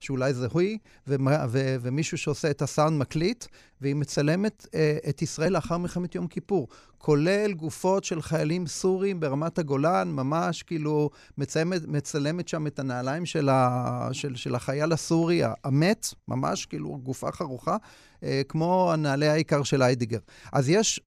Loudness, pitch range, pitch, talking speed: -27 LUFS, 140-175 Hz, 155 Hz, 140 wpm